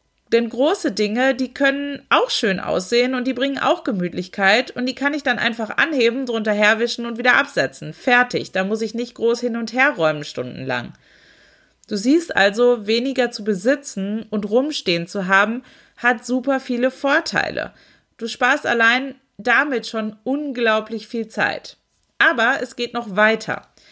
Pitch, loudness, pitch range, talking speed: 240 Hz, -19 LUFS, 215-260 Hz, 160 wpm